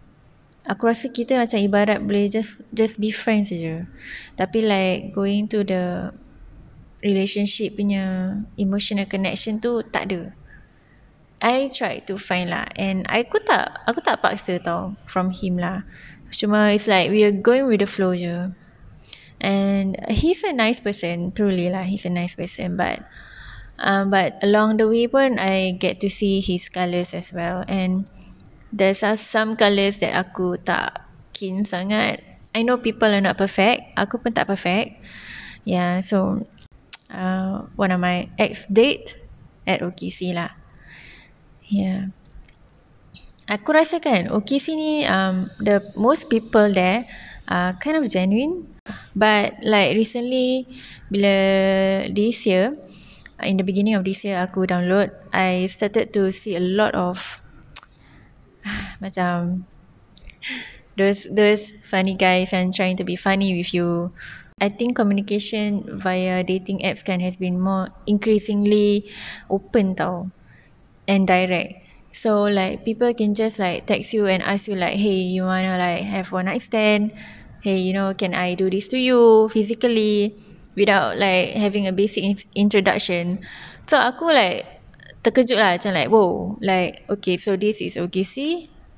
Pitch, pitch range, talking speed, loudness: 200 Hz, 185-215 Hz, 150 wpm, -20 LUFS